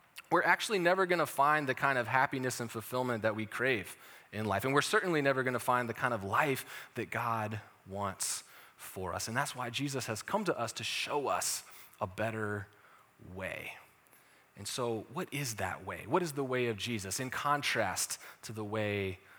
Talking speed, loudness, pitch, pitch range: 200 wpm, -33 LUFS, 120 Hz, 105-140 Hz